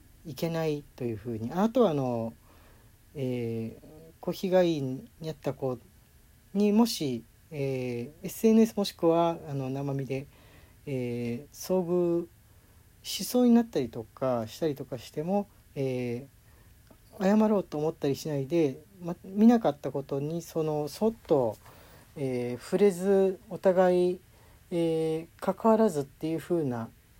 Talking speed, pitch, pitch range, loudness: 245 characters per minute, 150 Hz, 120-180 Hz, -29 LUFS